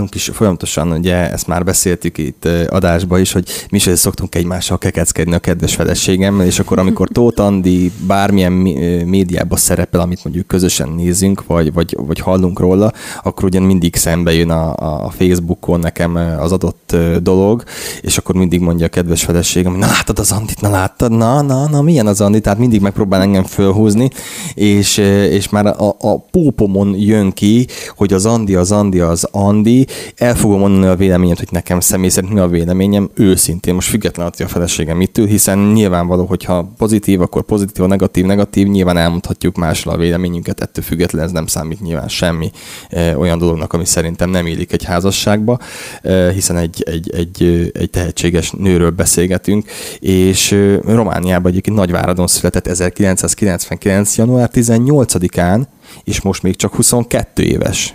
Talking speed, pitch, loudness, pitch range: 165 wpm, 95 Hz, -13 LUFS, 85-100 Hz